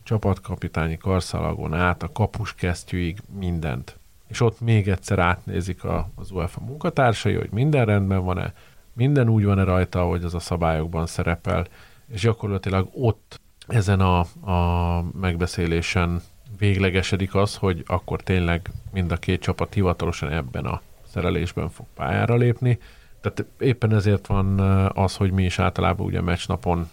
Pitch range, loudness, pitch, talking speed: 90-105 Hz, -23 LUFS, 95 Hz, 140 wpm